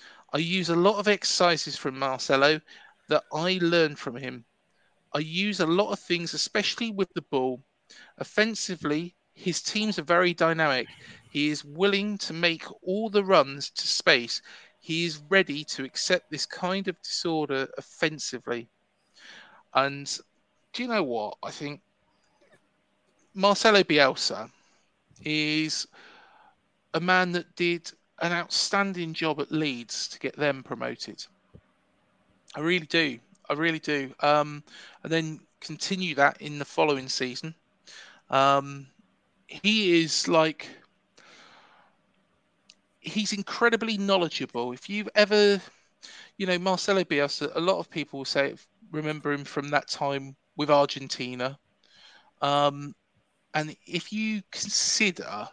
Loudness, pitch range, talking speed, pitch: -26 LUFS, 145-185 Hz, 130 wpm, 160 Hz